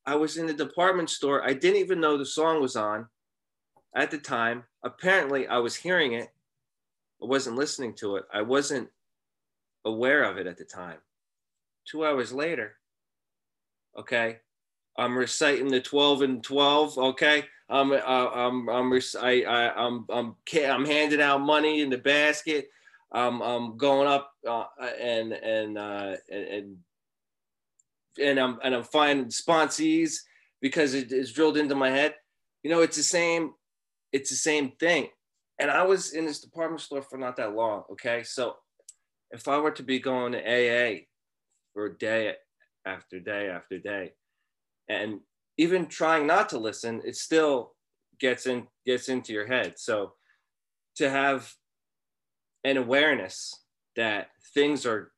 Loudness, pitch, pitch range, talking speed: -26 LUFS, 135 Hz, 120-150 Hz, 150 wpm